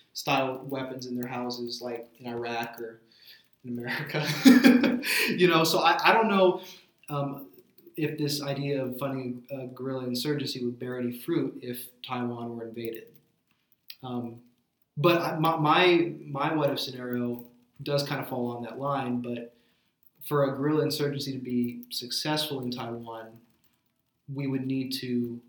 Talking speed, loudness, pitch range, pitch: 150 wpm, -27 LUFS, 120-145 Hz, 130 Hz